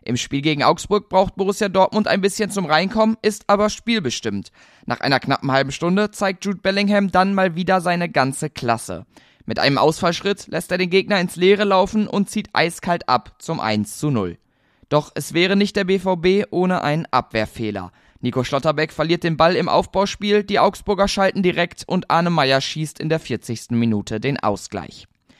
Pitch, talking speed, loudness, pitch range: 175 Hz, 180 wpm, -19 LUFS, 135-195 Hz